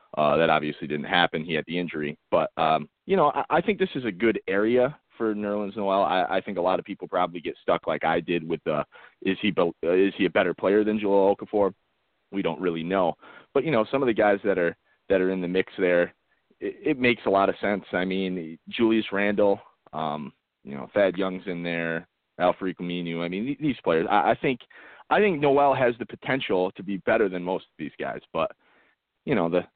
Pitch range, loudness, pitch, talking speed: 90-110 Hz, -25 LUFS, 100 Hz, 230 wpm